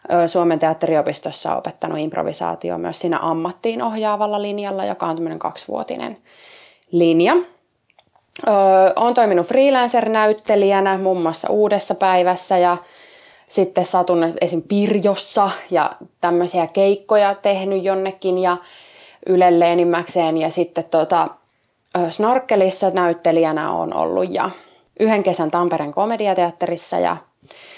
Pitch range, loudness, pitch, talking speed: 170-205 Hz, -18 LUFS, 185 Hz, 100 wpm